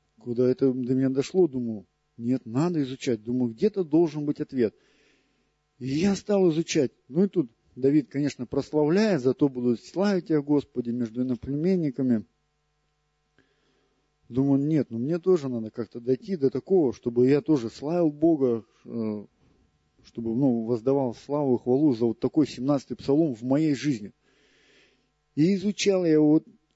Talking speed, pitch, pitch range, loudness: 145 wpm, 135 Hz, 120-155 Hz, -25 LUFS